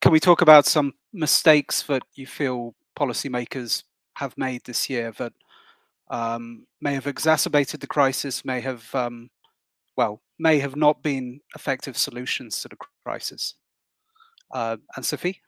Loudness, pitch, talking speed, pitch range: -23 LUFS, 140 Hz, 145 wpm, 125-155 Hz